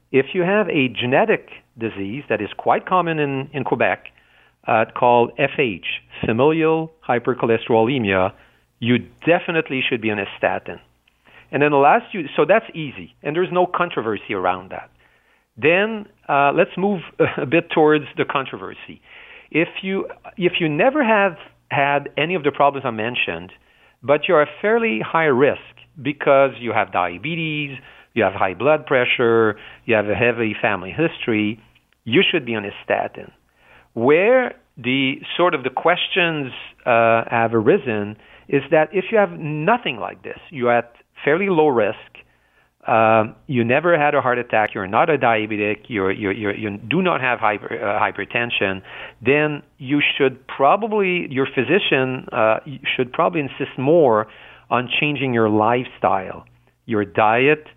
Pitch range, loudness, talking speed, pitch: 115-160 Hz, -19 LUFS, 155 wpm, 135 Hz